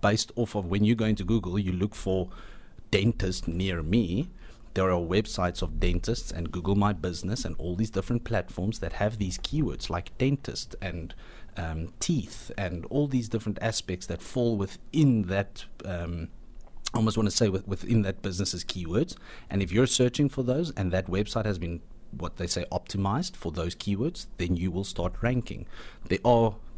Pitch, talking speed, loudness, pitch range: 100 Hz, 180 wpm, -29 LUFS, 90-115 Hz